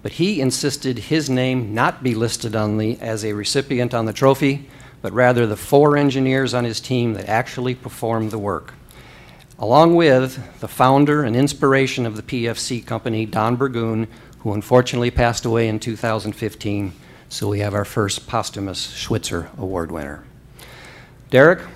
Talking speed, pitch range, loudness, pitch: 155 wpm, 110-130 Hz, -19 LUFS, 120 Hz